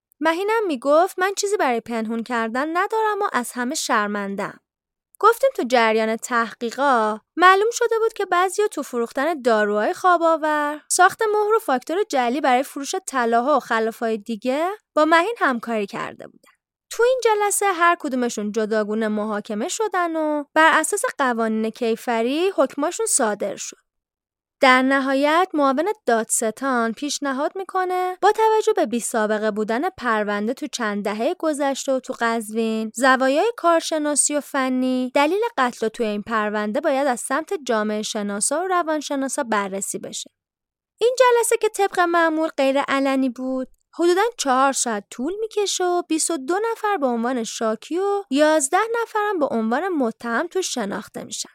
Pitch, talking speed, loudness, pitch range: 280 Hz, 145 wpm, -21 LUFS, 230-360 Hz